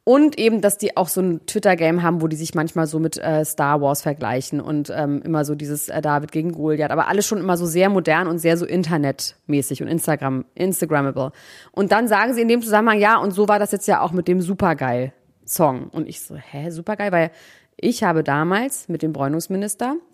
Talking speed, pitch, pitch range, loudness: 220 wpm, 165 Hz, 150-200 Hz, -20 LUFS